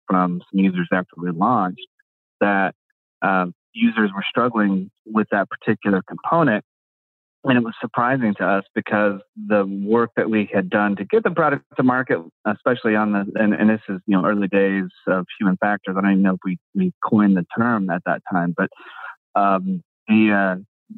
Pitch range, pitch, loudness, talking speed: 95-115 Hz, 105 Hz, -20 LUFS, 185 wpm